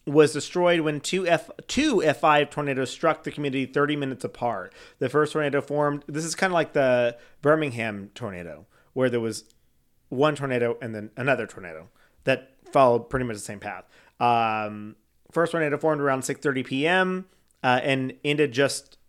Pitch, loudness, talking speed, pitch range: 140 Hz, -25 LUFS, 165 wpm, 125-150 Hz